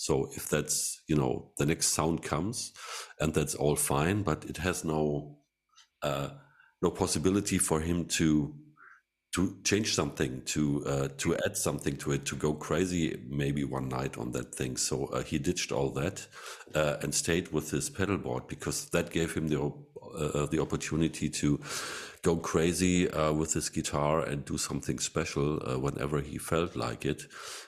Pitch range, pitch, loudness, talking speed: 70-80 Hz, 75 Hz, -31 LUFS, 175 wpm